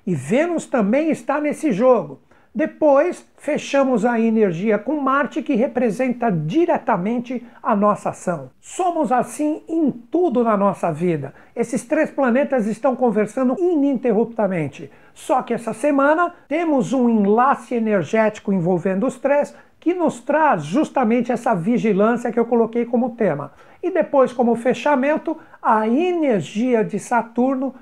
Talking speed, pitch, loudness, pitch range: 130 wpm, 250 Hz, -19 LUFS, 220-285 Hz